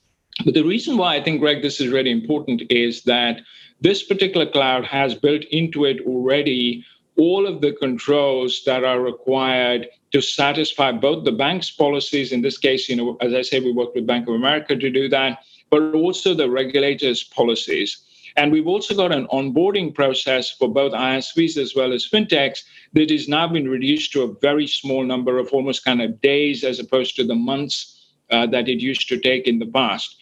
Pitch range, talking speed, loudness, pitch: 125-150 Hz, 195 wpm, -19 LUFS, 135 Hz